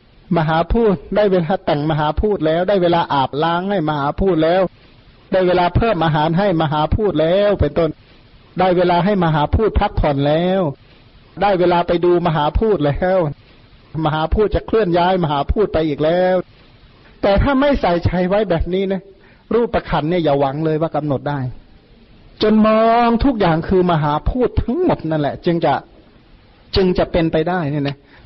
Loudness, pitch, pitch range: -17 LUFS, 170 Hz, 150-190 Hz